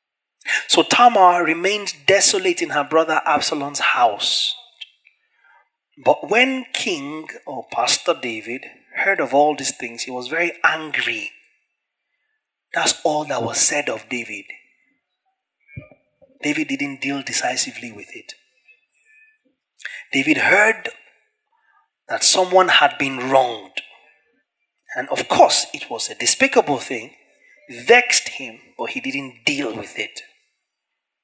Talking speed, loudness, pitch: 115 wpm, -18 LUFS, 200 Hz